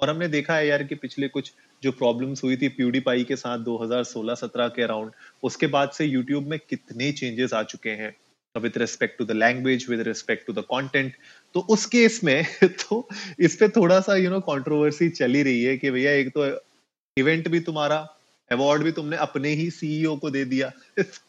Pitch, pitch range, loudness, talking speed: 140 Hz, 125-160 Hz, -24 LUFS, 200 wpm